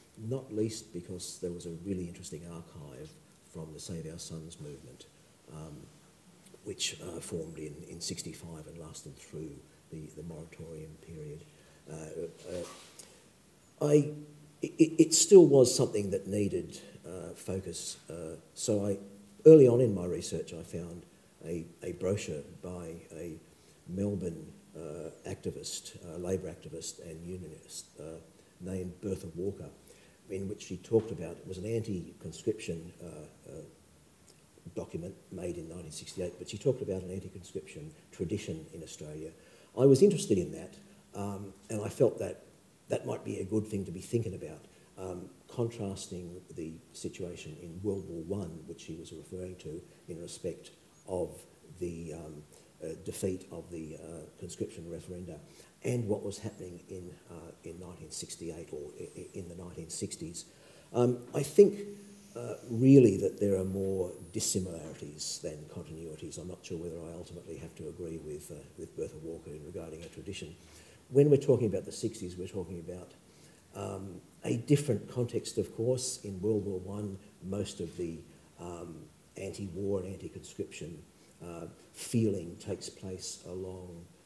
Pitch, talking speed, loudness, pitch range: 95 Hz, 150 wpm, -32 LUFS, 85-110 Hz